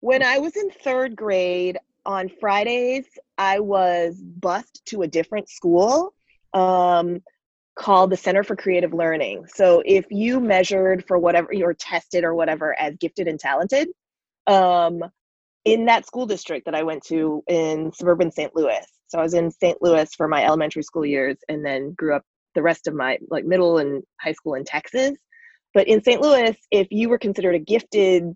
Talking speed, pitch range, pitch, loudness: 180 wpm, 165-215 Hz, 180 Hz, -21 LUFS